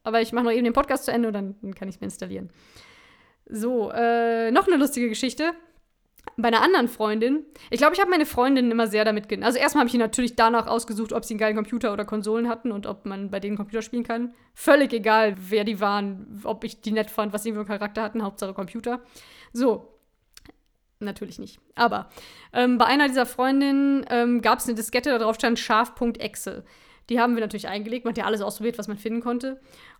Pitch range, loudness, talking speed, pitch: 215-245 Hz, -24 LUFS, 220 wpm, 230 Hz